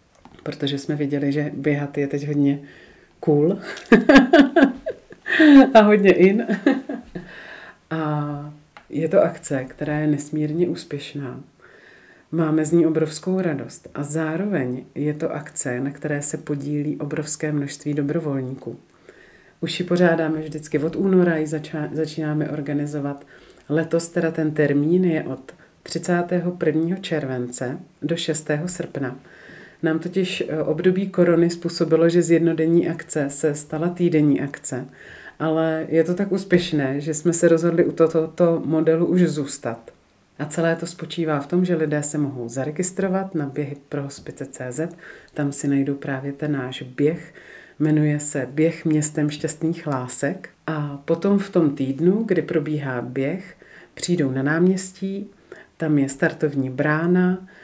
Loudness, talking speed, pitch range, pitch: -21 LUFS, 135 wpm, 145-170 Hz, 155 Hz